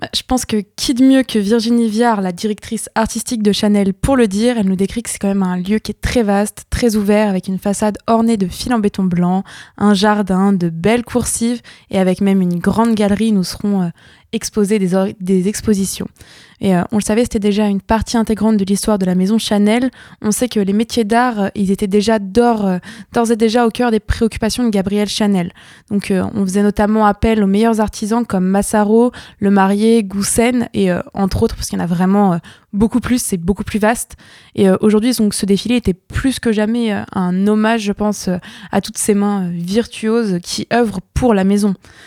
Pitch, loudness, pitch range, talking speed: 210 Hz, -15 LUFS, 195-230 Hz, 215 wpm